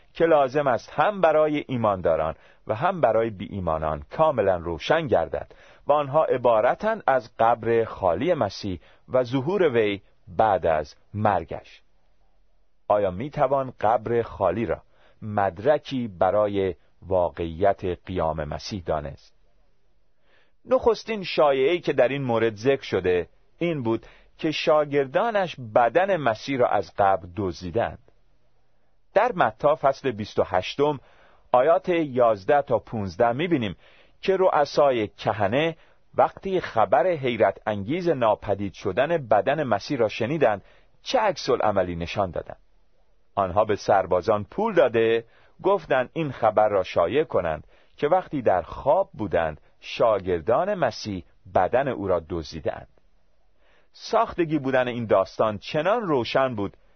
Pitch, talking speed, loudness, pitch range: 115 Hz, 120 wpm, -24 LUFS, 95-150 Hz